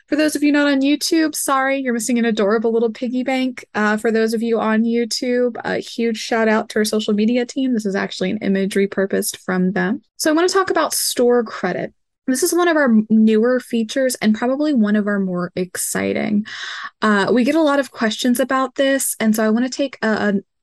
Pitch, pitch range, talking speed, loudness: 235 Hz, 215-270 Hz, 225 wpm, -18 LUFS